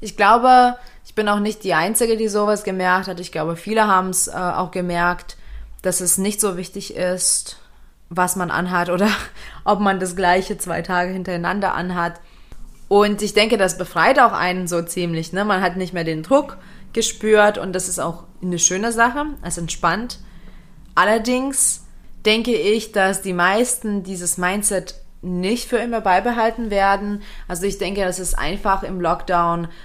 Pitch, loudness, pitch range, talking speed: 185 Hz, -19 LUFS, 180-210 Hz, 170 wpm